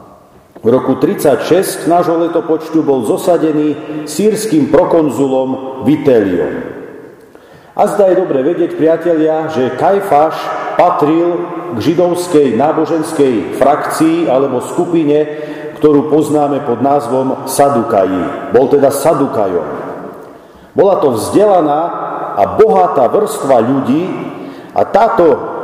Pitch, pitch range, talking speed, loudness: 155 Hz, 145-175 Hz, 100 wpm, -12 LUFS